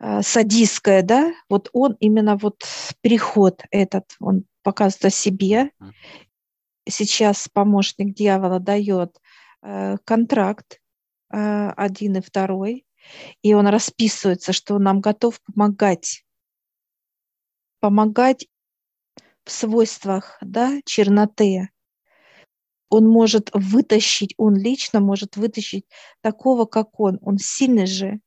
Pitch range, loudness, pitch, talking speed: 195-220 Hz, -19 LUFS, 205 Hz, 100 wpm